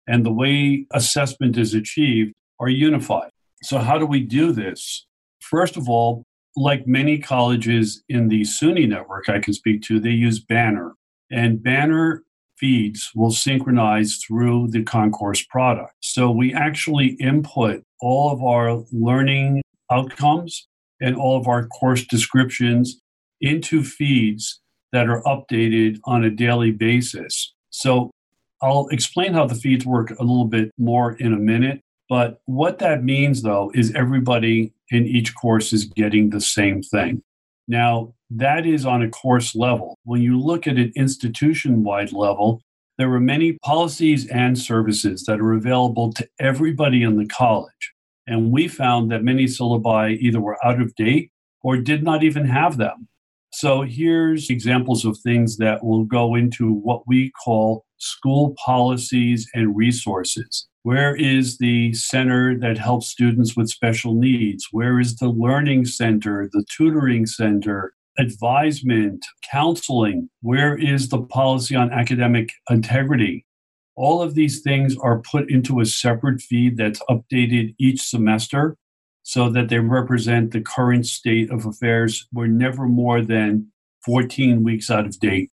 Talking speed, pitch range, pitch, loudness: 150 wpm, 115-130 Hz, 120 Hz, -19 LUFS